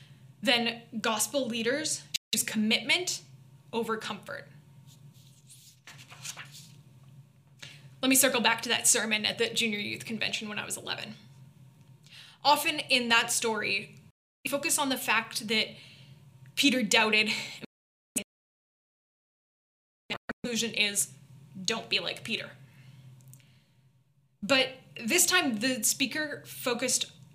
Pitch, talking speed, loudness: 215 Hz, 105 wpm, -28 LUFS